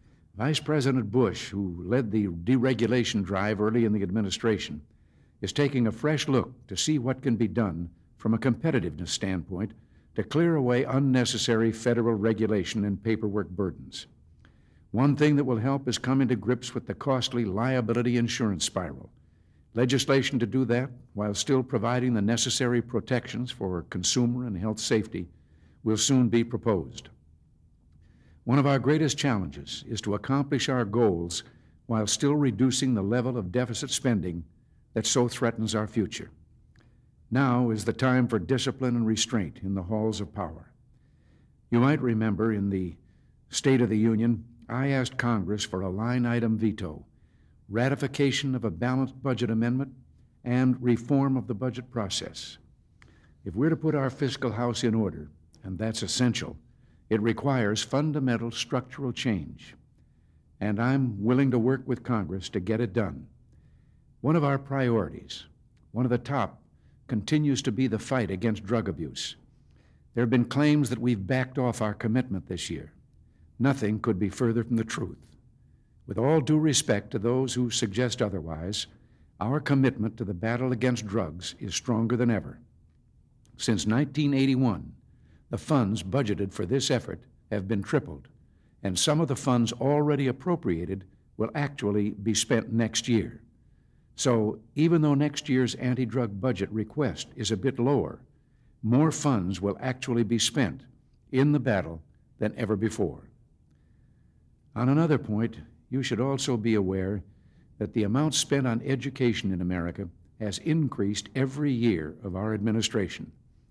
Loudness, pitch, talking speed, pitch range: -27 LUFS, 115 Hz, 155 wpm, 105-130 Hz